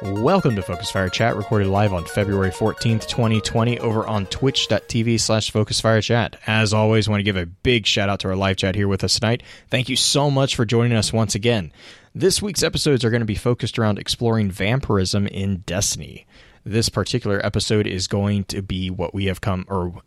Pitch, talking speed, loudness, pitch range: 110 Hz, 210 wpm, -20 LUFS, 100-115 Hz